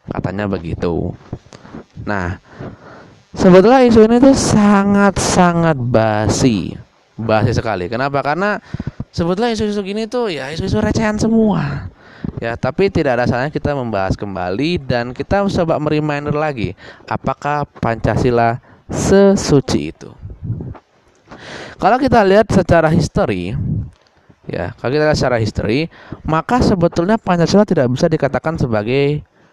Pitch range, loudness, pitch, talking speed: 120-195 Hz, -15 LUFS, 150 Hz, 115 wpm